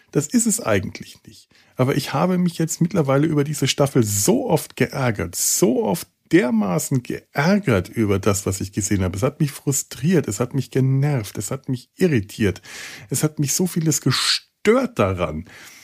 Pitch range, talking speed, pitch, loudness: 110-155 Hz, 175 wpm, 135 Hz, -20 LUFS